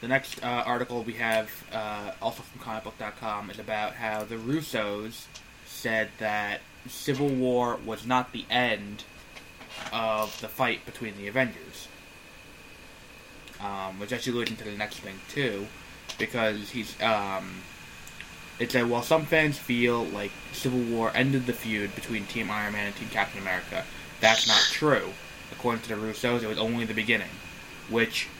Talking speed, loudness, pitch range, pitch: 155 wpm, -28 LUFS, 105-125 Hz, 110 Hz